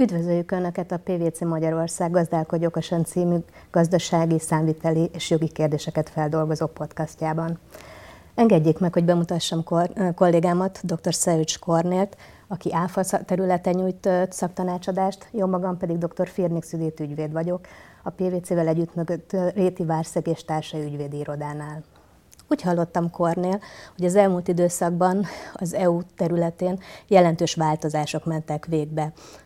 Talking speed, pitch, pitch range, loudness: 120 wpm, 170 Hz, 160-180 Hz, -24 LUFS